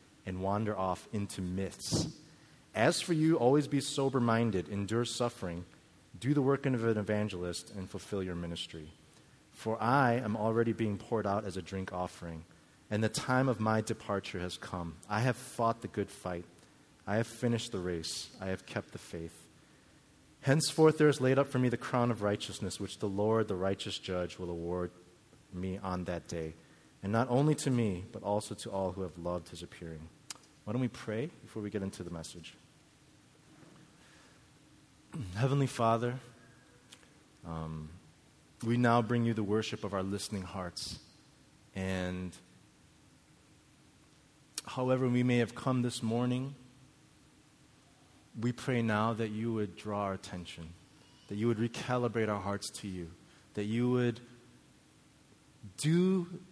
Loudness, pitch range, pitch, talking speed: -34 LUFS, 95-130 Hz, 110 Hz, 155 wpm